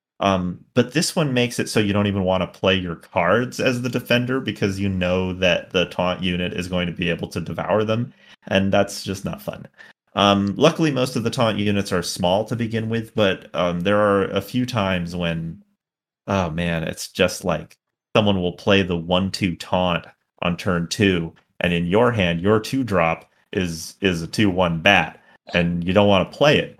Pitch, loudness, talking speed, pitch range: 100 Hz, -21 LUFS, 205 wpm, 90-110 Hz